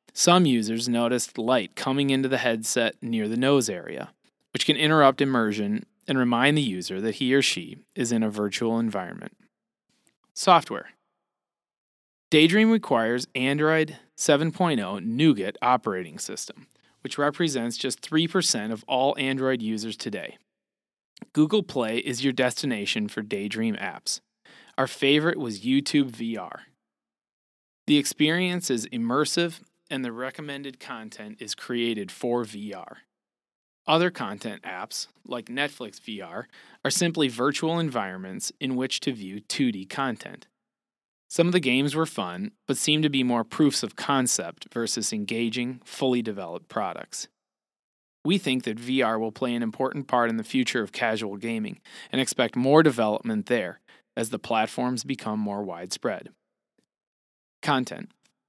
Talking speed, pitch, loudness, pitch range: 135 wpm, 130 Hz, -25 LUFS, 115-155 Hz